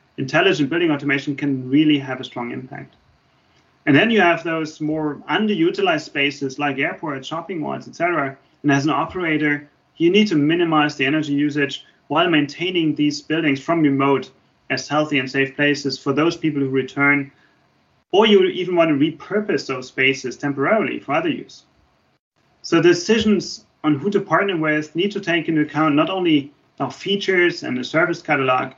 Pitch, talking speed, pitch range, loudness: 150 Hz, 170 wpm, 140-170 Hz, -19 LUFS